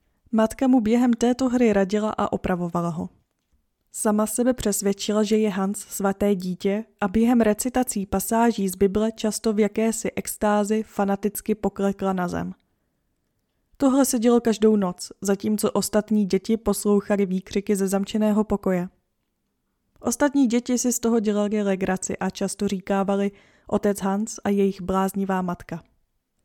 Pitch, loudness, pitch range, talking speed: 205 Hz, -23 LUFS, 195-220 Hz, 135 wpm